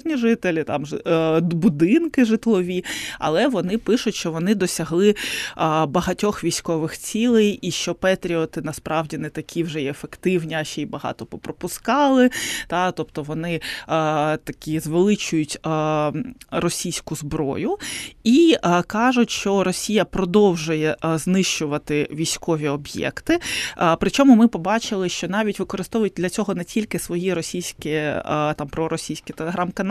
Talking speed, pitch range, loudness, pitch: 110 wpm, 160-210 Hz, -21 LUFS, 175 Hz